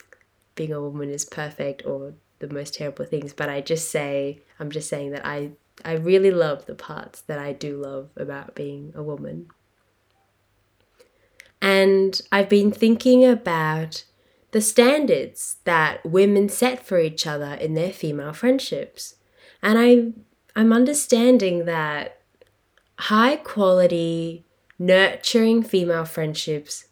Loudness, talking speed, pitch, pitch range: -21 LUFS, 130 wpm, 165 Hz, 145-215 Hz